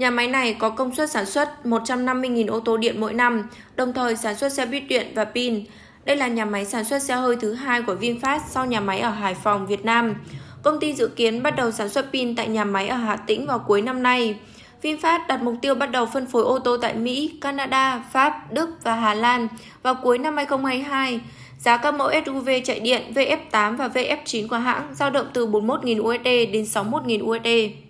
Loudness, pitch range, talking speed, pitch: -22 LUFS, 225-265 Hz, 220 wpm, 245 Hz